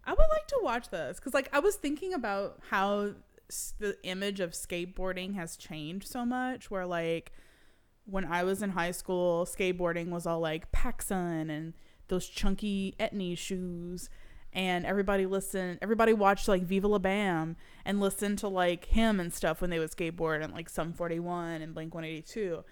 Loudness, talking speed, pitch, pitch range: -32 LUFS, 175 wpm, 185 Hz, 170-200 Hz